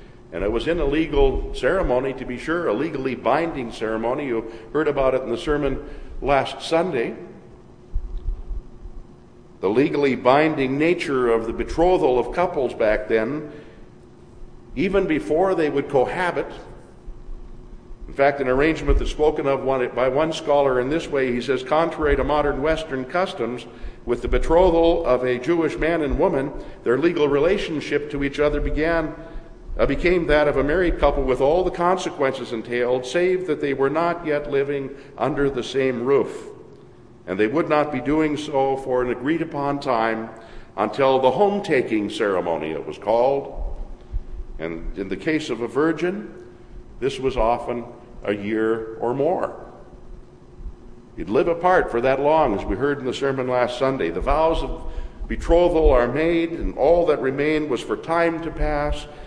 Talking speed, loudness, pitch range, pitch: 160 wpm, -21 LUFS, 120-160 Hz, 140 Hz